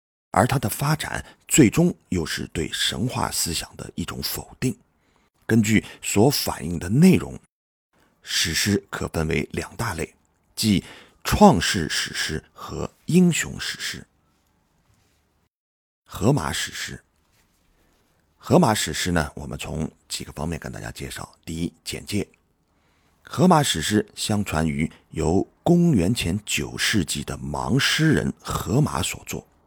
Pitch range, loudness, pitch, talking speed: 80-105 Hz, -23 LUFS, 85 Hz, 185 characters per minute